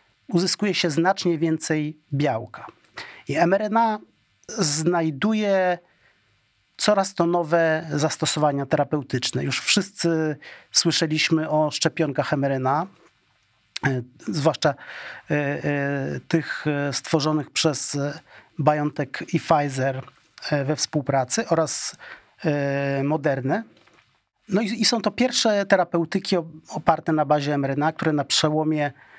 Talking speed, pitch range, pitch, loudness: 90 wpm, 145-170 Hz, 155 Hz, -22 LUFS